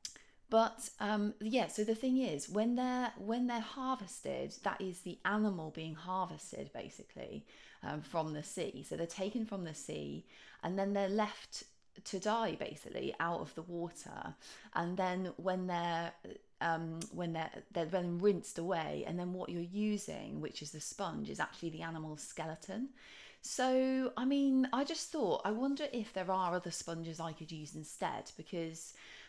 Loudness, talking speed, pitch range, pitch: -38 LUFS, 170 wpm, 165-225 Hz, 190 Hz